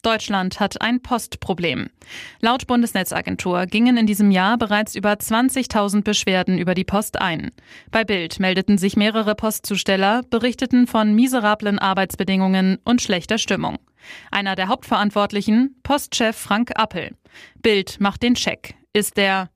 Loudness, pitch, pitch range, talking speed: -19 LUFS, 210 Hz, 195-230 Hz, 130 wpm